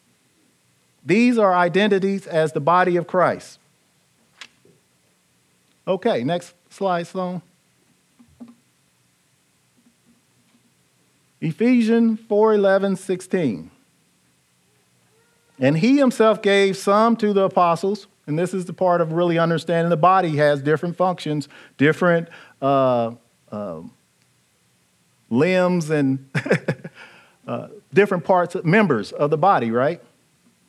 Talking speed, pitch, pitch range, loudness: 100 wpm, 175 Hz, 135-195 Hz, -19 LUFS